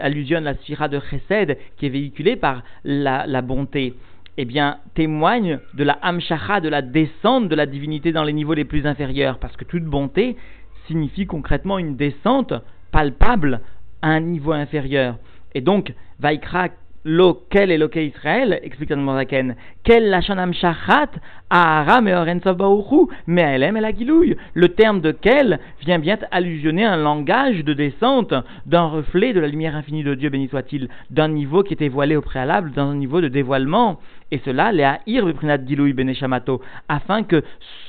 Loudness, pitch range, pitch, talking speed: -19 LUFS, 140-175 Hz, 150 Hz, 170 wpm